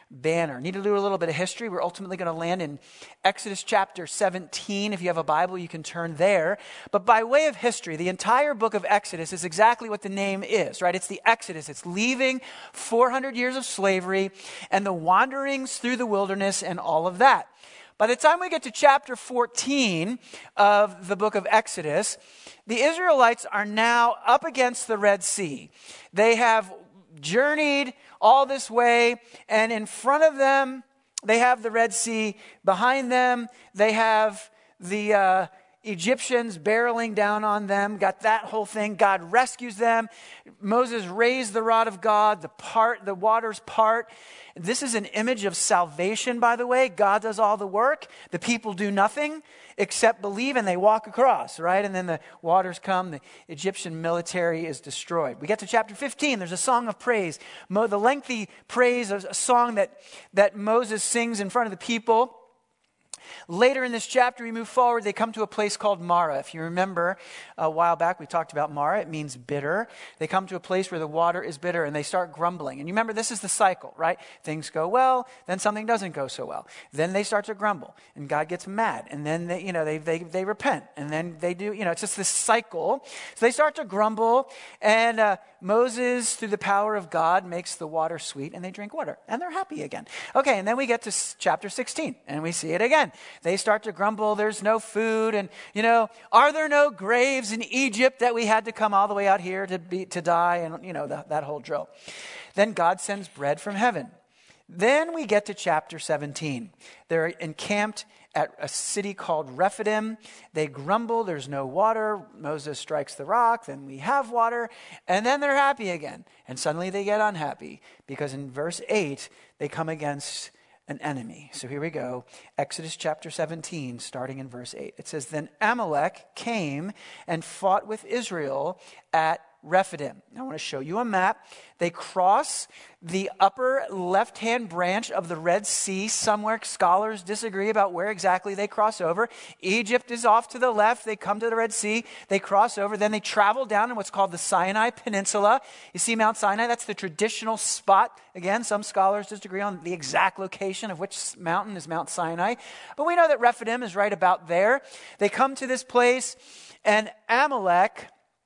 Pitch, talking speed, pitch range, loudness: 205 Hz, 195 wpm, 175-230 Hz, -25 LUFS